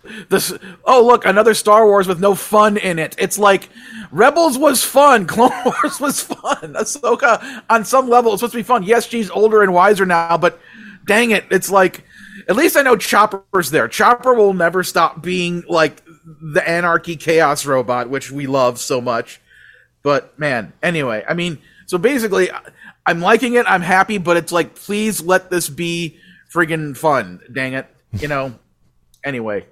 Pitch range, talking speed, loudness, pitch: 165-220 Hz, 175 wpm, -15 LUFS, 190 Hz